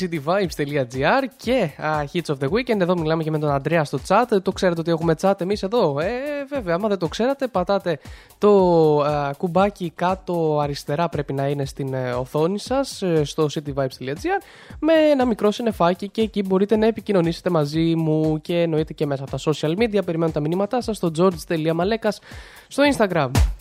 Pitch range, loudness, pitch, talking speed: 155-205 Hz, -21 LUFS, 170 Hz, 180 wpm